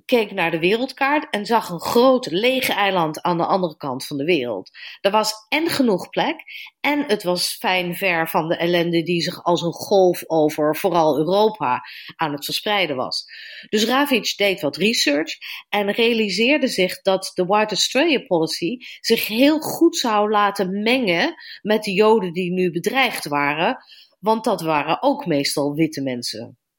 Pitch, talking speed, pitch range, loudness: 200 Hz, 170 wpm, 170-240 Hz, -20 LUFS